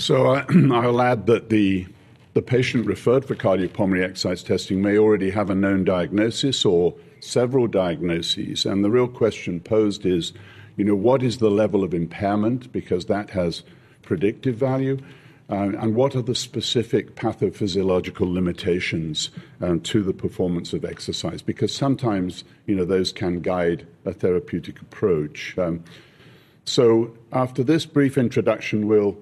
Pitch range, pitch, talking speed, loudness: 95-125 Hz, 105 Hz, 150 wpm, -22 LUFS